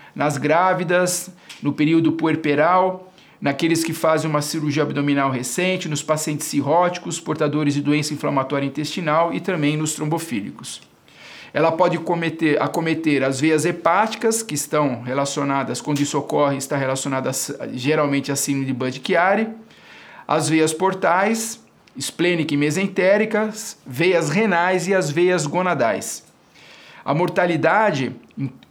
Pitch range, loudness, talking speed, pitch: 145-180 Hz, -20 LUFS, 120 wpm, 155 Hz